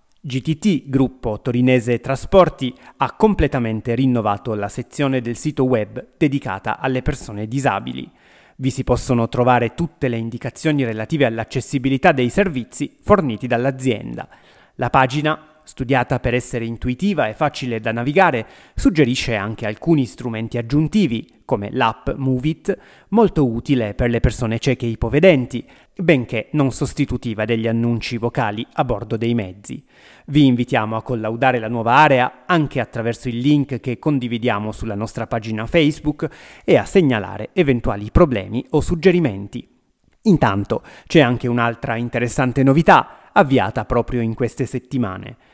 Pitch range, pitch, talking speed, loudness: 115-145 Hz, 125 Hz, 135 wpm, -19 LUFS